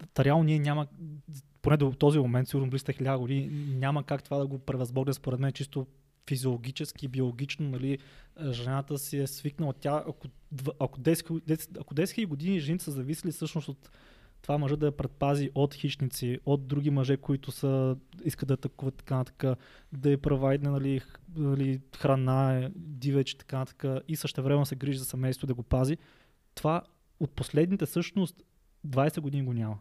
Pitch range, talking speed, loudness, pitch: 135-150 Hz, 175 wpm, -31 LUFS, 140 Hz